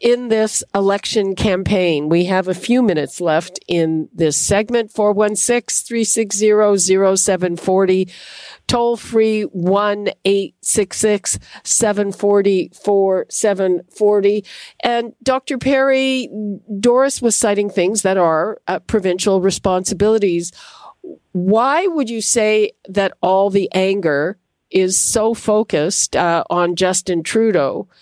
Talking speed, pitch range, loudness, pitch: 100 wpm, 185-225 Hz, -16 LUFS, 205 Hz